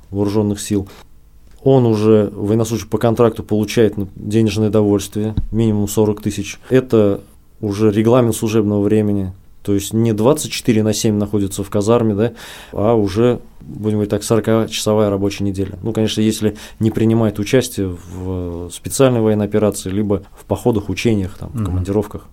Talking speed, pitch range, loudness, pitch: 140 wpm, 100-110 Hz, -17 LUFS, 105 Hz